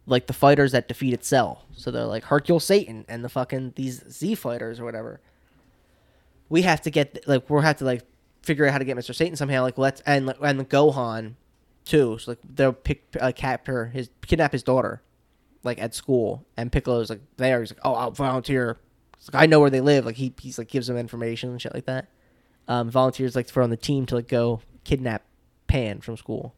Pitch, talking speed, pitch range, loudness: 130 Hz, 220 wpm, 120-140 Hz, -24 LUFS